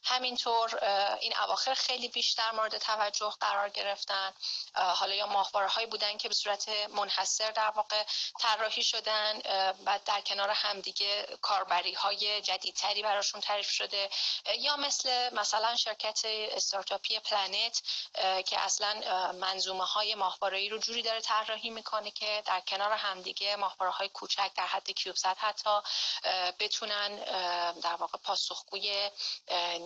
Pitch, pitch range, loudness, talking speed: 205 Hz, 195-215 Hz, -31 LUFS, 125 wpm